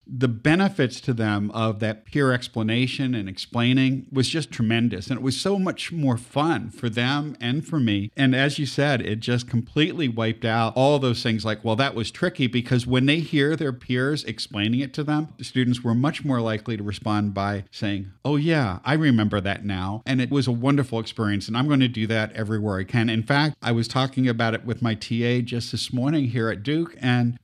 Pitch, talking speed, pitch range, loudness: 125 Hz, 220 wpm, 110-140 Hz, -23 LUFS